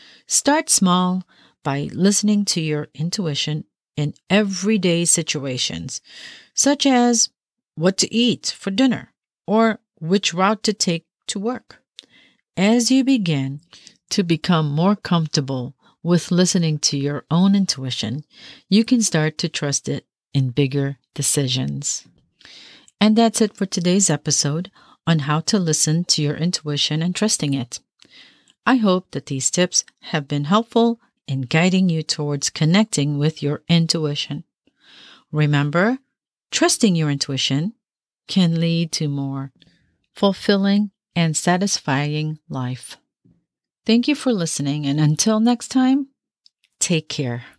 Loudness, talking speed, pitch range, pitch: -19 LUFS, 125 wpm, 145-210 Hz, 170 Hz